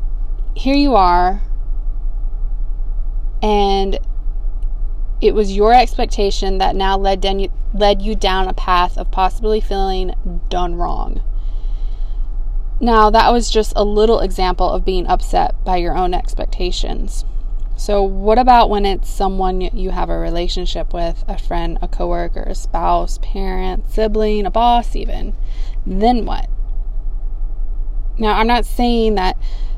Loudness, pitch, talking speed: -18 LUFS, 185 Hz, 130 wpm